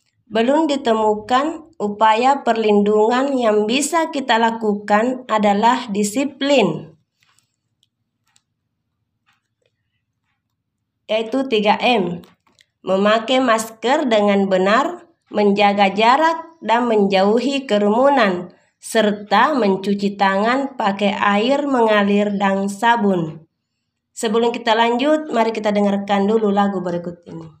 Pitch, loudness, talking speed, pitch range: 210 Hz, -17 LUFS, 85 wpm, 190-235 Hz